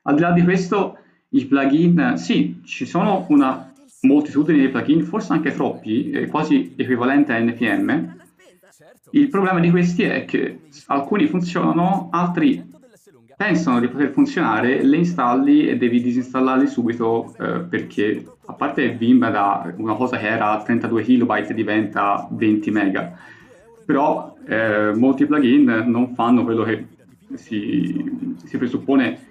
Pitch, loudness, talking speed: 140 Hz, -19 LUFS, 135 wpm